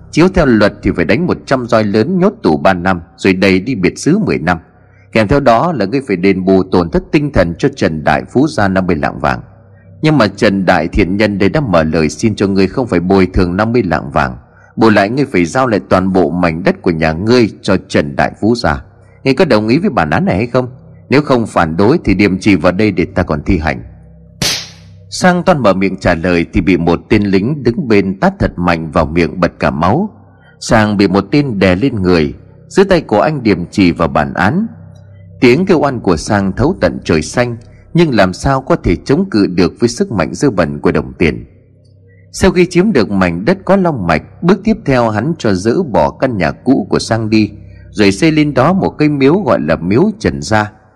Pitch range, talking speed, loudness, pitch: 90-125 Hz, 235 wpm, -12 LUFS, 100 Hz